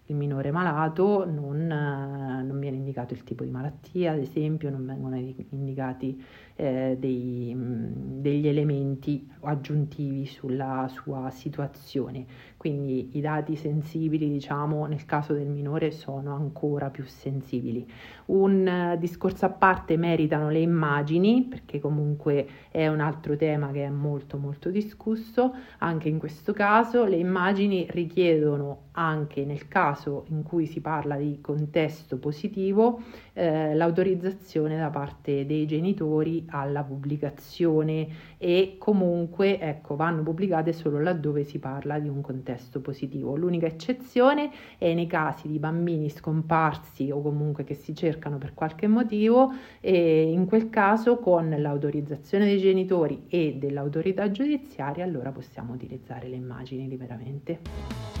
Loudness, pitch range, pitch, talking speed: -27 LUFS, 140-170 Hz, 150 Hz, 130 wpm